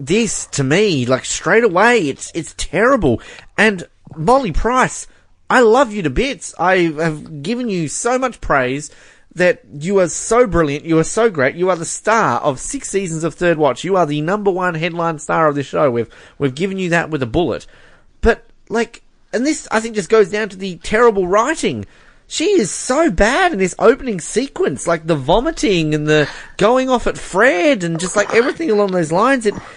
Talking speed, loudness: 200 wpm, -16 LUFS